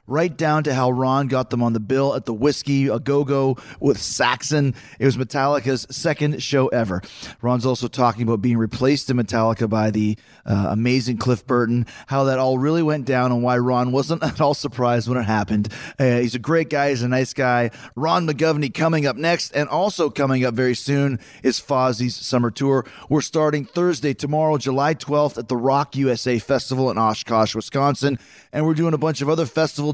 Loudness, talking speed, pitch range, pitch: -20 LUFS, 200 wpm, 120-145 Hz, 130 Hz